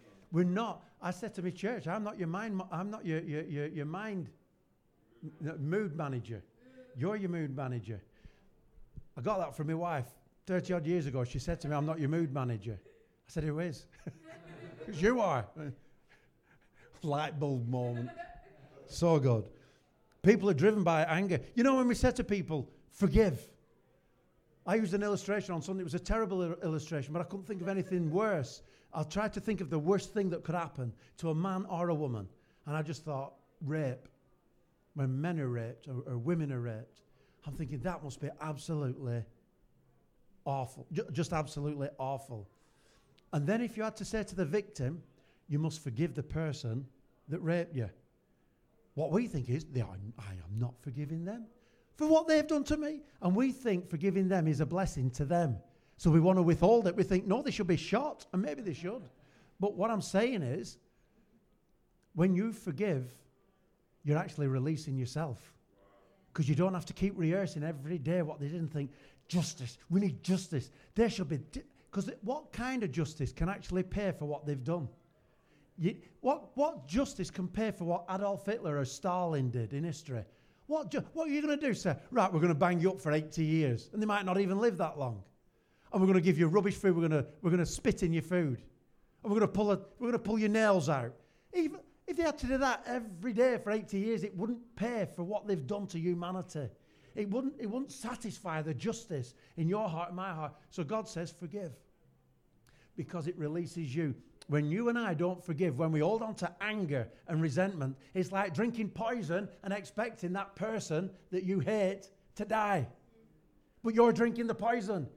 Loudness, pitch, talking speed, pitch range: -34 LUFS, 175 Hz, 195 wpm, 145-205 Hz